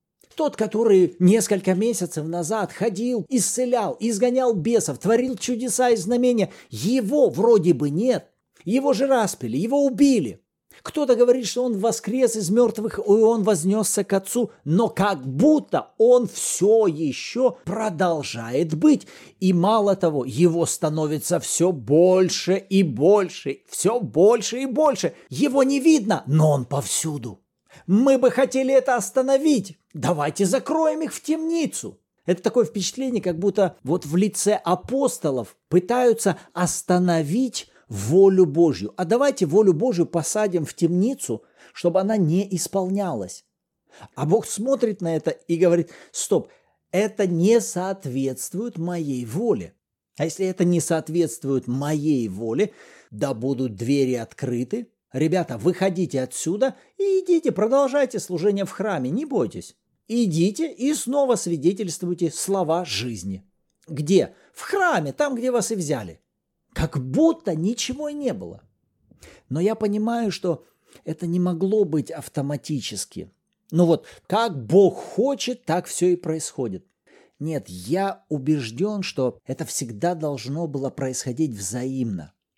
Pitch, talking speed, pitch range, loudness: 190 Hz, 130 wpm, 160-235 Hz, -22 LUFS